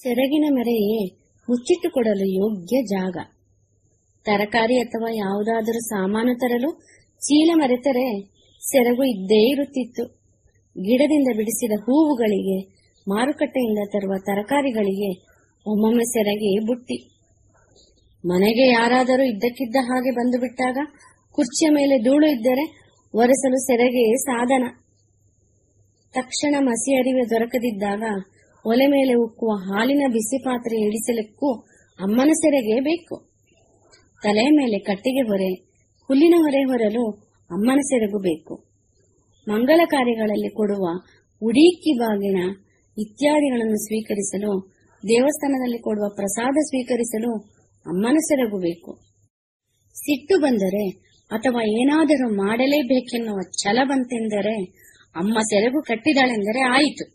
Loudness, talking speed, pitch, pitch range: -20 LUFS, 90 wpm, 230 Hz, 205-265 Hz